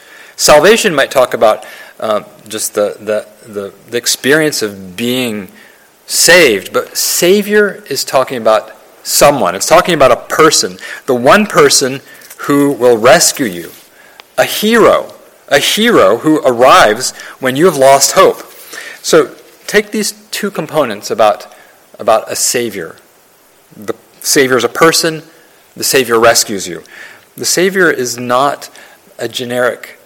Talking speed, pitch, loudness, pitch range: 135 wpm, 140 Hz, -10 LUFS, 120-185 Hz